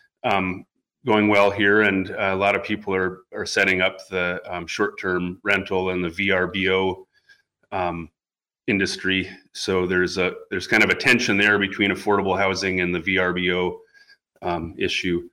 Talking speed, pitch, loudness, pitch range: 155 wpm, 95 Hz, -21 LUFS, 90-100 Hz